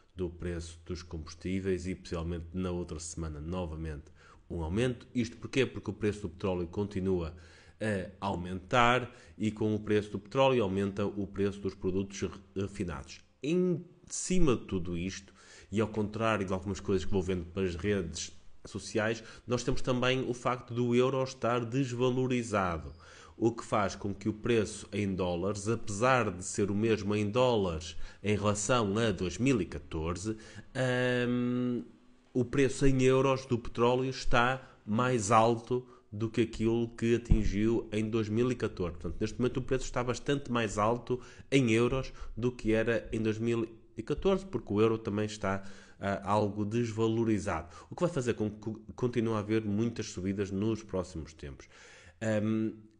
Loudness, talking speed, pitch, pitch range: -32 LUFS, 155 wpm, 110 Hz, 95-120 Hz